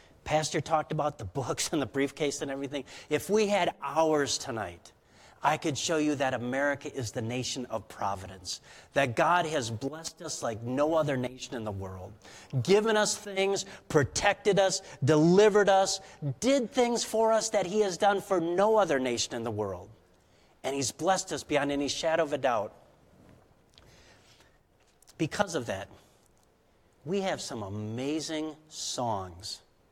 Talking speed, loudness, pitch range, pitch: 155 wpm, -29 LUFS, 120-175 Hz, 145 Hz